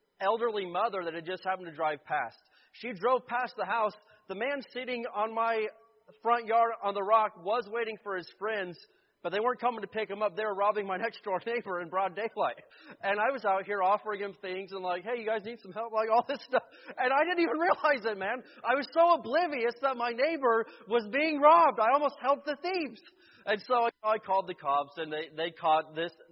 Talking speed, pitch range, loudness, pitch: 230 wpm, 195-245 Hz, -30 LUFS, 220 Hz